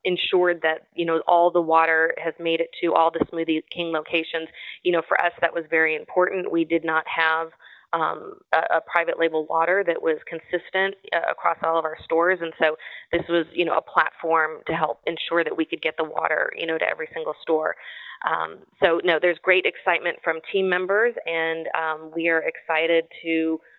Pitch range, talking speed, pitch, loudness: 160-180 Hz, 205 wpm, 165 Hz, -23 LUFS